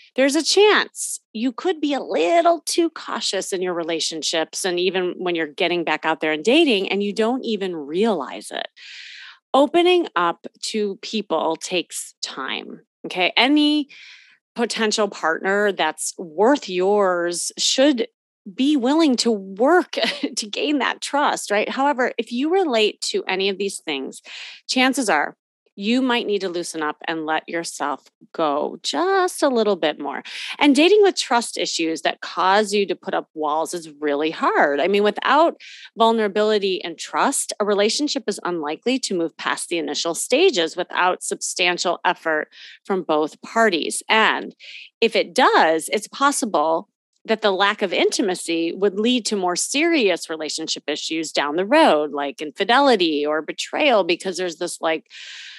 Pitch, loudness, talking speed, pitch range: 200 Hz, -20 LUFS, 155 wpm, 170-255 Hz